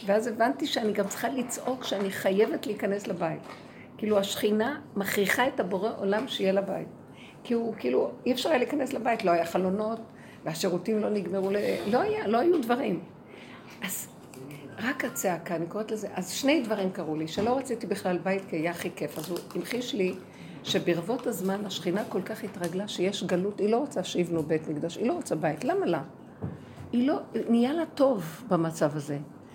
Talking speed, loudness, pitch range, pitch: 175 wpm, -29 LUFS, 180-235 Hz, 200 Hz